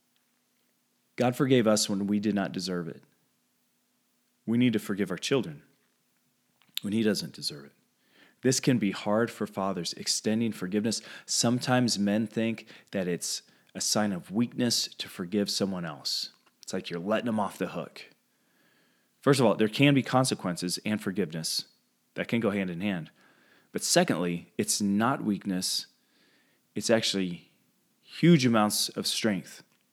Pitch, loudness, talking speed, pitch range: 105 Hz, -28 LUFS, 150 wpm, 95-120 Hz